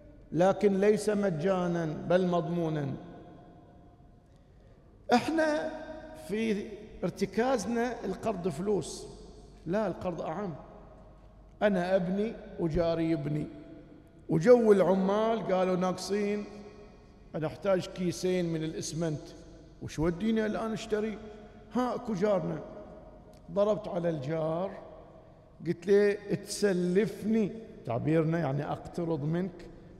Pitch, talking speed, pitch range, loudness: 190 Hz, 85 wpm, 170-210 Hz, -30 LUFS